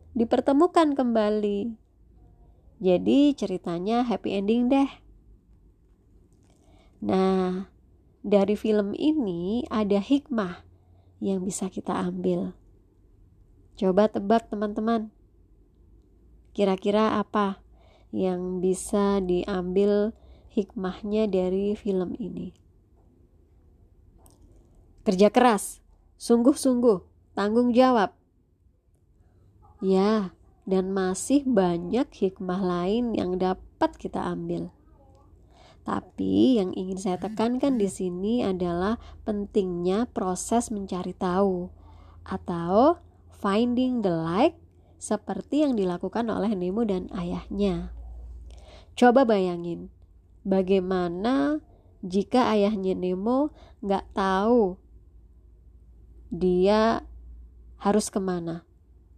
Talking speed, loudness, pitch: 80 wpm, -25 LUFS, 190 Hz